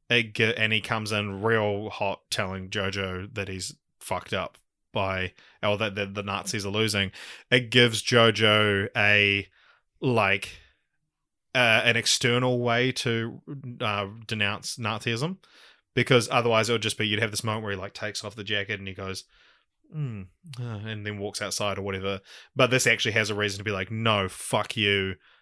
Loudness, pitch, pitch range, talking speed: -25 LUFS, 105 Hz, 100-115 Hz, 175 wpm